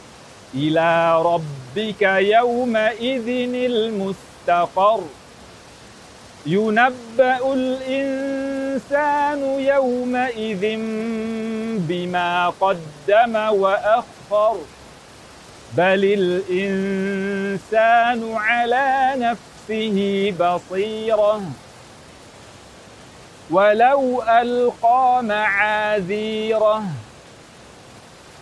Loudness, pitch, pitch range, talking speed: -19 LUFS, 220 Hz, 195-250 Hz, 40 wpm